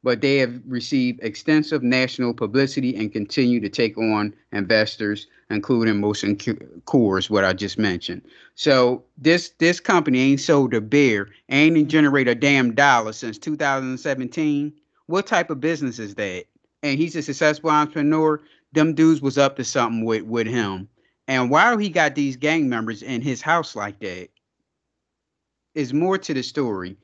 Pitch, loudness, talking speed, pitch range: 130 Hz, -21 LUFS, 160 wpm, 110-150 Hz